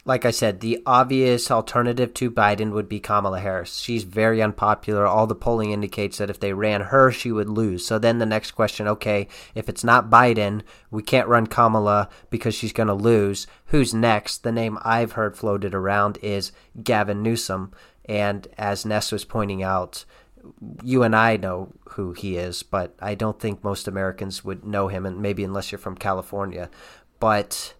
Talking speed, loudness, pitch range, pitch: 185 wpm, -22 LUFS, 100-115 Hz, 105 Hz